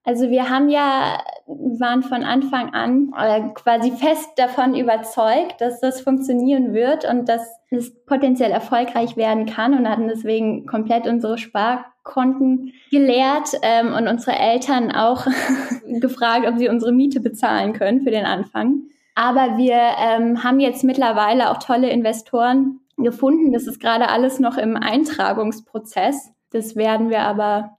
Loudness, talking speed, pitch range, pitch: -18 LUFS, 145 wpm, 230-265 Hz, 245 Hz